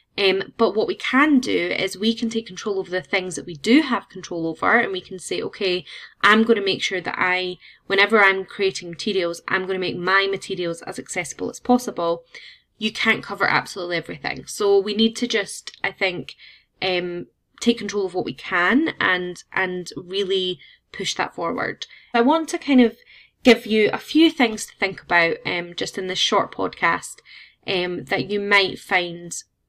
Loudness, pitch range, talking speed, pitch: -21 LUFS, 180-225 Hz, 190 wpm, 195 Hz